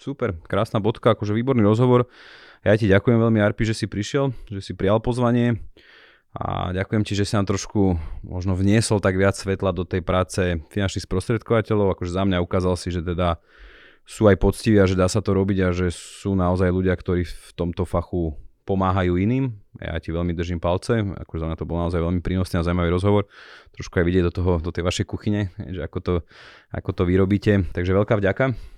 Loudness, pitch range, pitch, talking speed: -22 LUFS, 90-105 Hz, 95 Hz, 200 wpm